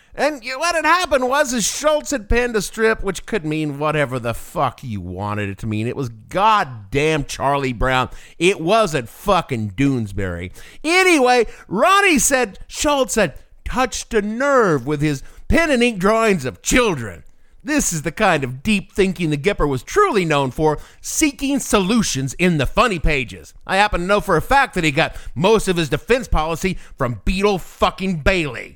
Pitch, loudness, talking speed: 185 Hz, -18 LUFS, 175 wpm